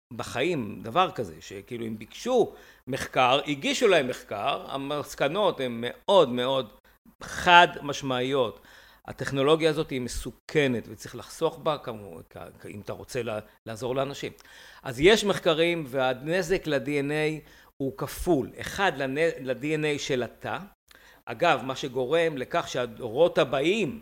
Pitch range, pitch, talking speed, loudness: 125-160 Hz, 140 Hz, 120 wpm, -26 LUFS